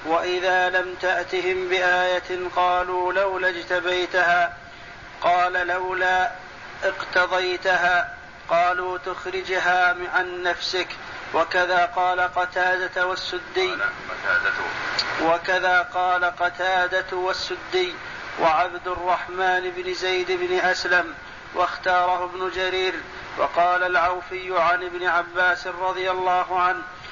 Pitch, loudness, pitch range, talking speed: 180 Hz, -22 LUFS, 180-185 Hz, 85 wpm